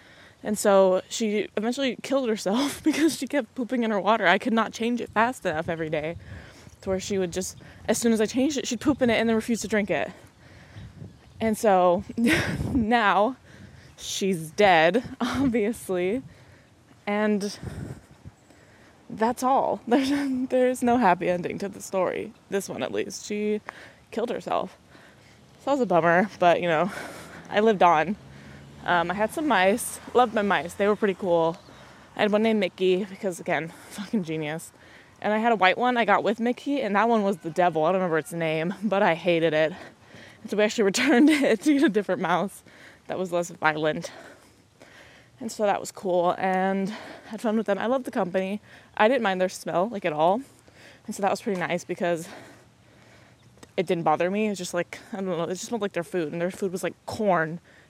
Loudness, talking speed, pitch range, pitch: -25 LUFS, 200 wpm, 175-225 Hz, 200 Hz